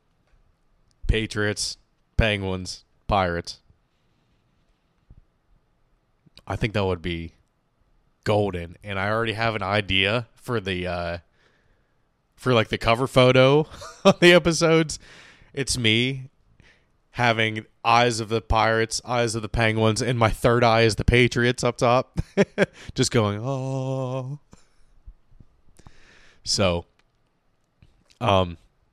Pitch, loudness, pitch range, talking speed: 115 Hz, -22 LUFS, 100-130 Hz, 105 wpm